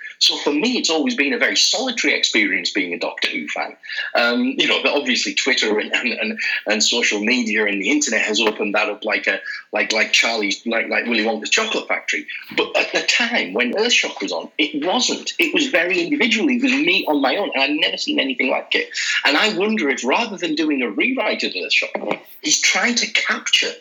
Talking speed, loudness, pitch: 215 wpm, -18 LUFS, 255 Hz